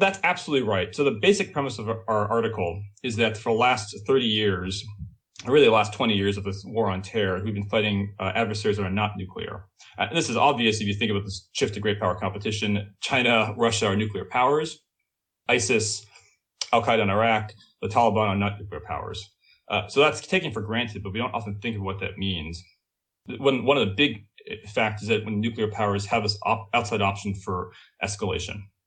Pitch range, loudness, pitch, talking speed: 100-115 Hz, -25 LUFS, 105 Hz, 210 wpm